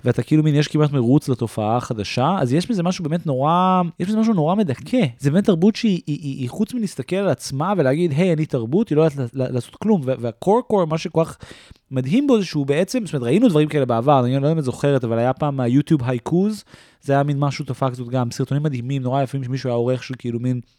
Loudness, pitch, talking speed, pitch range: -20 LUFS, 145 Hz, 235 wpm, 130-180 Hz